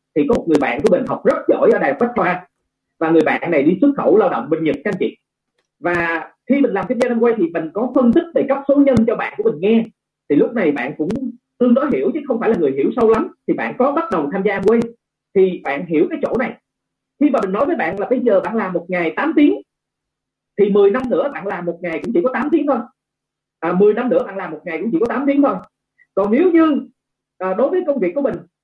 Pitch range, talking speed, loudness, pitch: 180-275 Hz, 275 wpm, -17 LUFS, 230 Hz